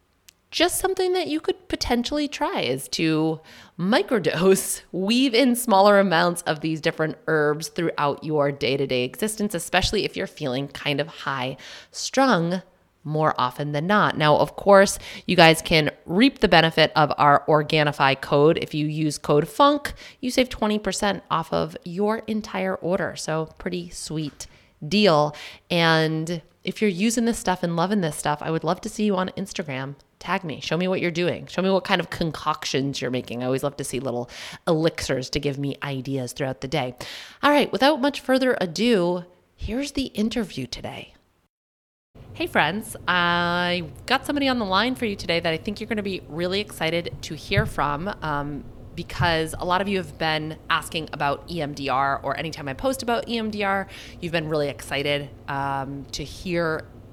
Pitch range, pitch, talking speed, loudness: 145-200 Hz, 170 Hz, 180 wpm, -23 LUFS